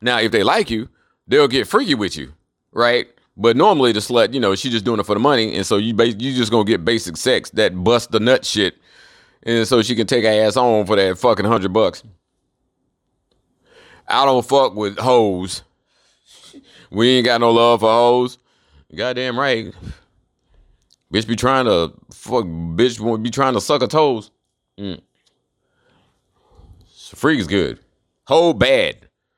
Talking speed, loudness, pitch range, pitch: 175 wpm, -17 LUFS, 105-125 Hz, 115 Hz